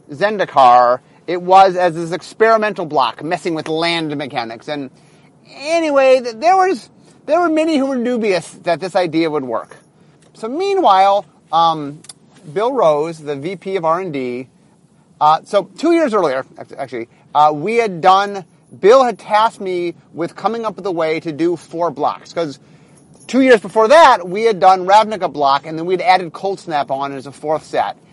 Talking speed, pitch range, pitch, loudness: 170 wpm, 155-210 Hz, 180 Hz, -15 LUFS